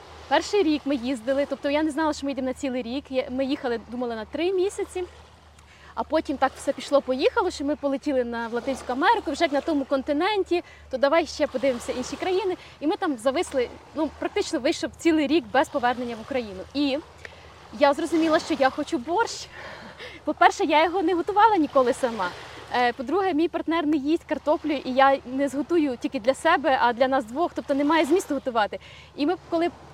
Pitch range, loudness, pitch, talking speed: 270-335 Hz, -24 LUFS, 290 Hz, 185 wpm